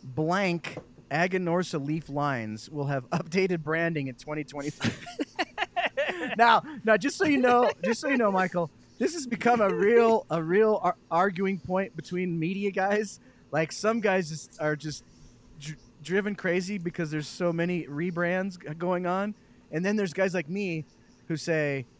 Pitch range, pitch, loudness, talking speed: 155-200 Hz, 175 Hz, -28 LUFS, 160 wpm